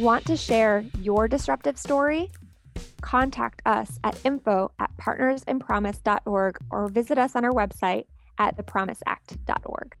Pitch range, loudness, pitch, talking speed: 195-260 Hz, -25 LUFS, 220 Hz, 115 wpm